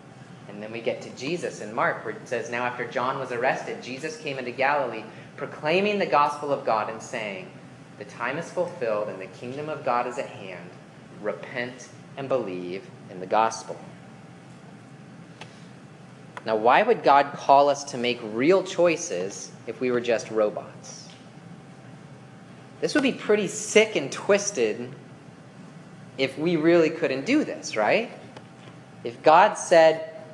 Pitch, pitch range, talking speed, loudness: 145 Hz, 125-170 Hz, 150 wpm, -24 LUFS